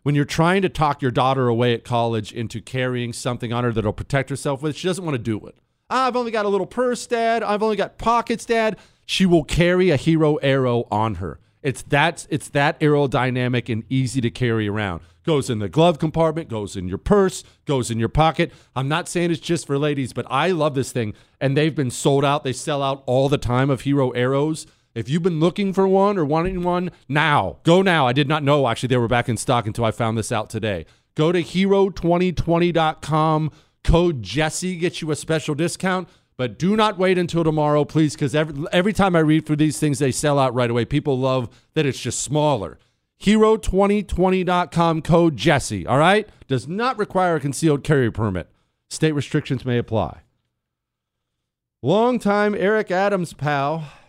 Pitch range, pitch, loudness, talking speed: 125-175 Hz, 150 Hz, -20 LUFS, 200 wpm